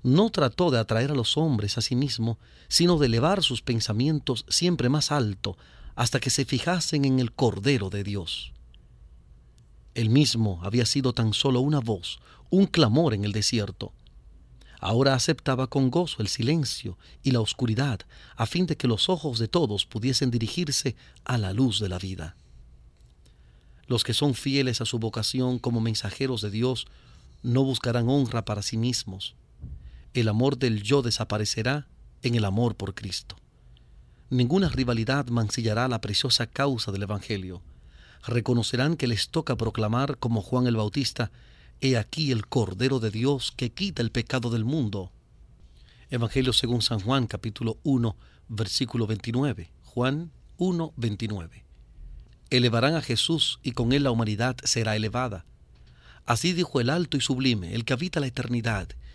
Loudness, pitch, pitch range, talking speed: -26 LUFS, 120 Hz, 100-135 Hz, 155 wpm